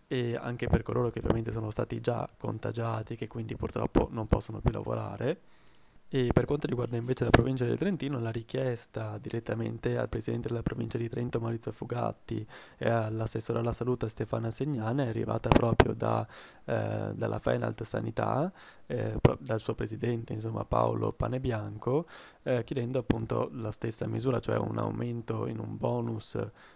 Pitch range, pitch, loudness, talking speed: 110-125 Hz, 115 Hz, -32 LUFS, 160 wpm